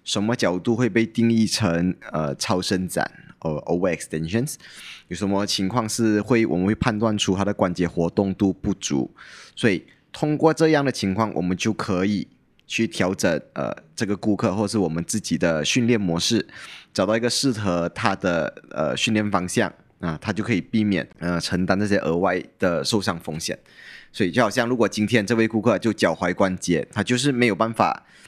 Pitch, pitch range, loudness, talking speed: 105 Hz, 90-115 Hz, -22 LUFS, 300 characters per minute